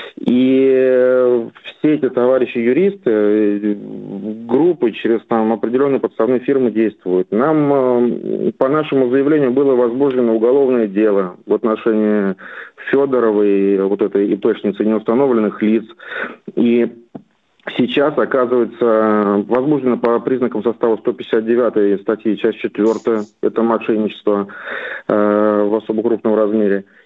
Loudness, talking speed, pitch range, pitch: -16 LUFS, 105 wpm, 105-125 Hz, 115 Hz